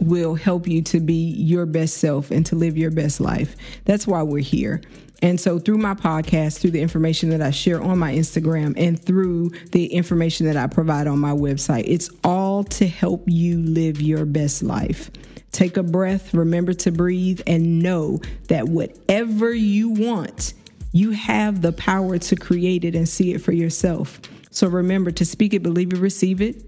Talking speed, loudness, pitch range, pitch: 190 wpm, -20 LUFS, 160-190 Hz, 175 Hz